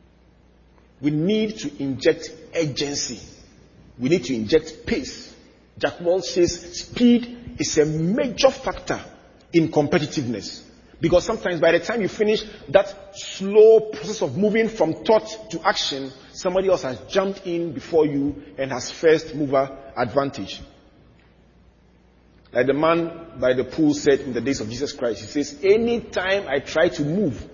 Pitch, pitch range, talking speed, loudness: 160 Hz, 140-195 Hz, 150 wpm, -22 LUFS